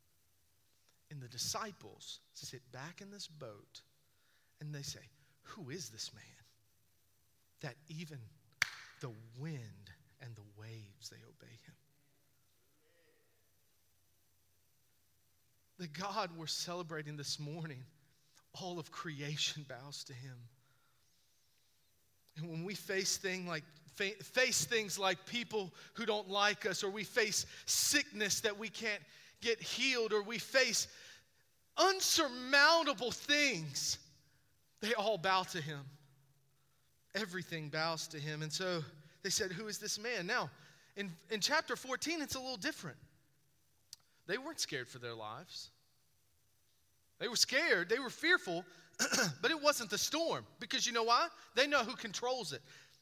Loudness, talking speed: -36 LUFS, 130 wpm